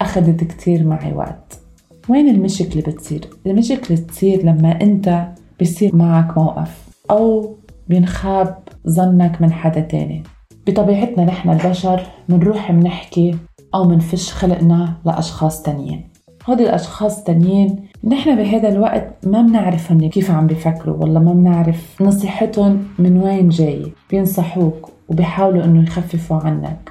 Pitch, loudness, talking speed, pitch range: 175 Hz, -15 LUFS, 120 wpm, 165-195 Hz